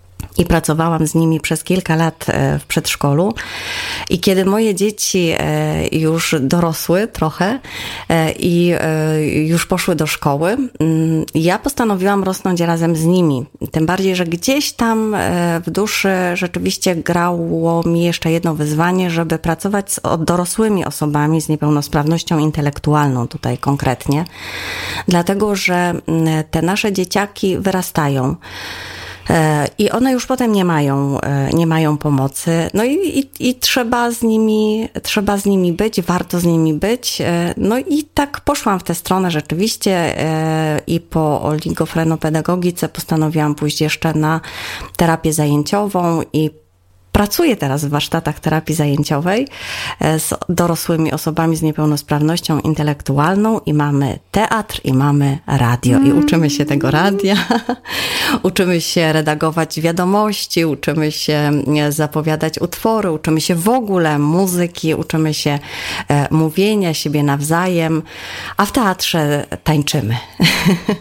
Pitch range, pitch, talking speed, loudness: 150-185 Hz, 165 Hz, 120 wpm, -16 LUFS